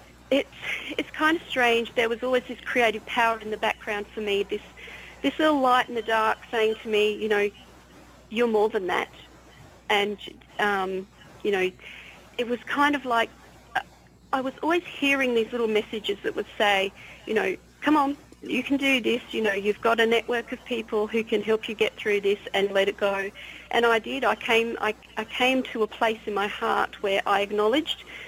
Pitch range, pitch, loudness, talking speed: 210-255 Hz, 230 Hz, -25 LUFS, 200 wpm